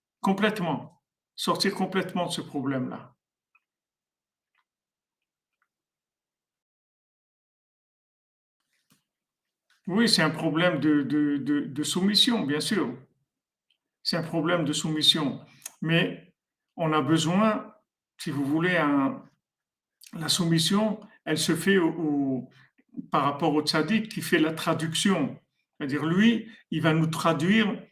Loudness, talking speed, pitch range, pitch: -25 LUFS, 110 wpm, 155-200 Hz, 165 Hz